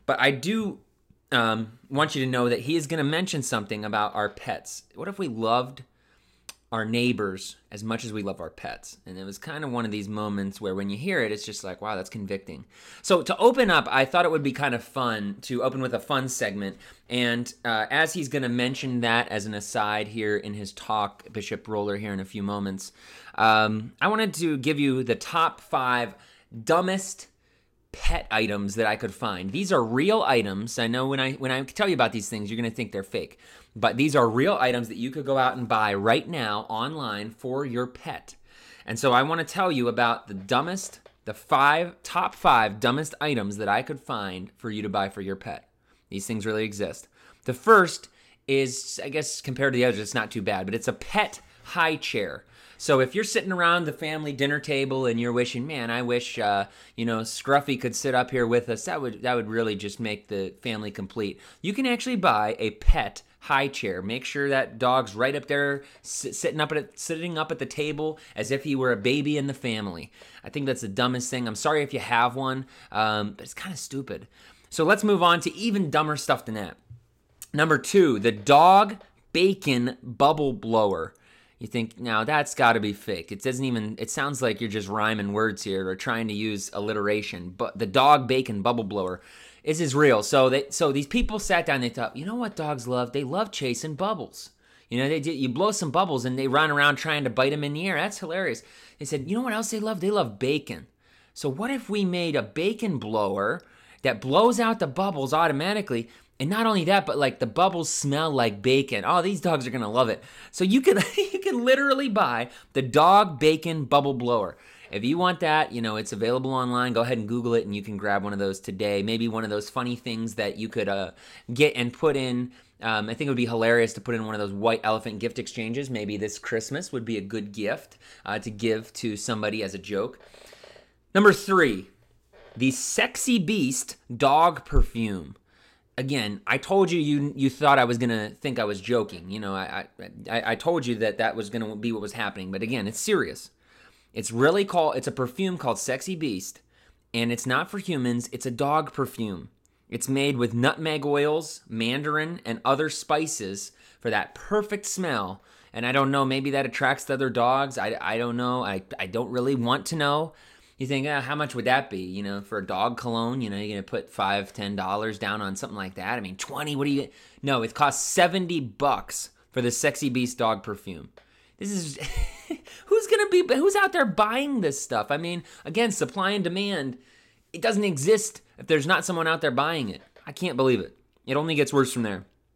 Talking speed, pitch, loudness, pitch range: 220 wpm, 125 Hz, -25 LUFS, 110-150 Hz